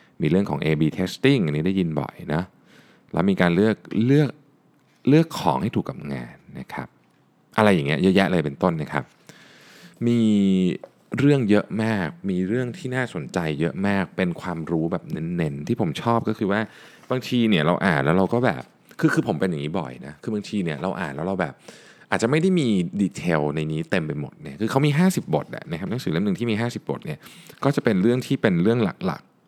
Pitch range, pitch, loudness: 85-125 Hz, 105 Hz, -23 LUFS